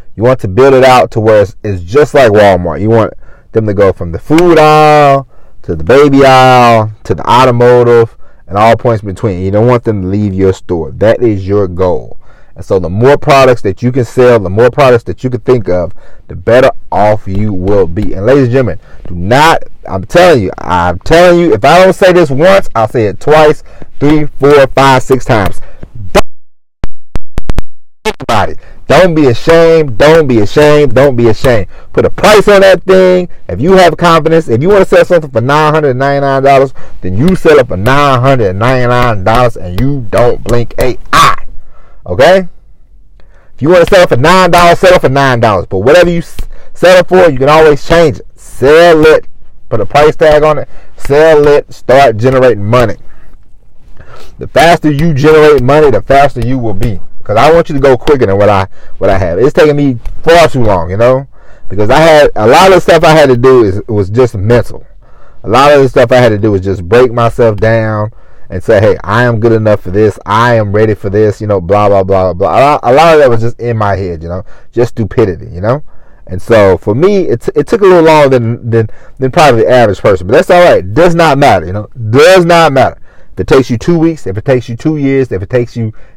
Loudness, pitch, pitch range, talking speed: -7 LUFS, 125 Hz, 105-150 Hz, 220 wpm